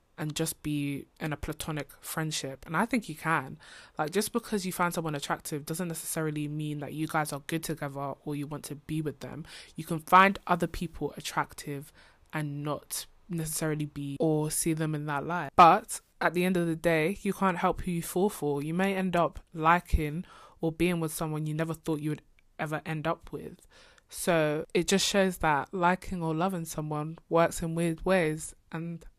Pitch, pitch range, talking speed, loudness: 160 Hz, 150-175 Hz, 200 wpm, -30 LUFS